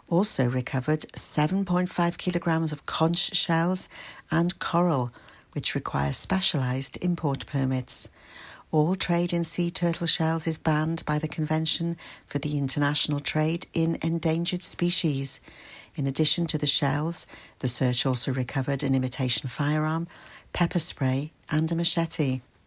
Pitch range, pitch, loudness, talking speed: 135-170 Hz, 155 Hz, -25 LUFS, 130 wpm